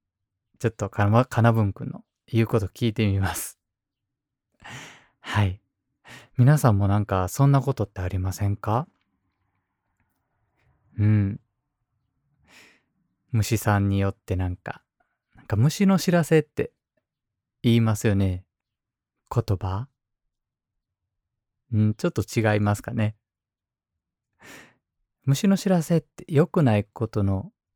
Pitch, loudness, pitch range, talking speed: 110 Hz, -24 LUFS, 100-125 Hz, 215 characters per minute